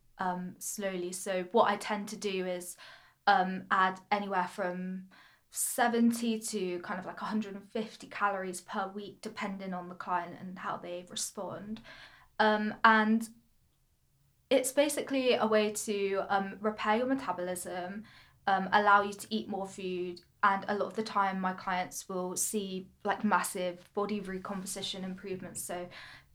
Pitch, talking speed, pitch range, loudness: 195 Hz, 145 wpm, 185-215 Hz, -32 LUFS